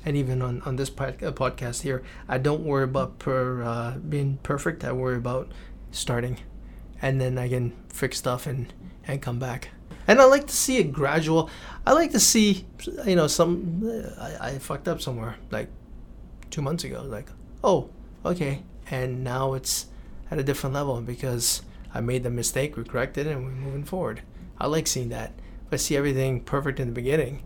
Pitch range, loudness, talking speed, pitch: 125-150 Hz, -26 LUFS, 190 wpm, 135 Hz